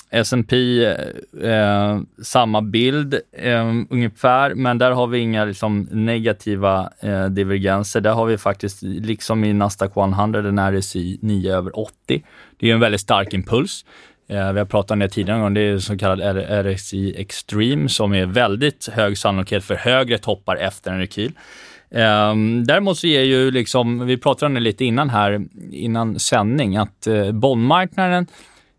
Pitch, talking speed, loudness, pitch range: 110 Hz, 155 wpm, -19 LUFS, 100-120 Hz